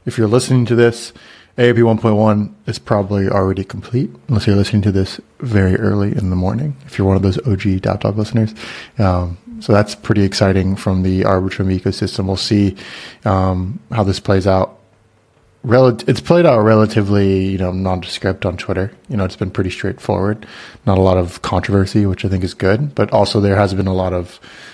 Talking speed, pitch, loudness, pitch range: 190 wpm, 100 Hz, -16 LUFS, 95-110 Hz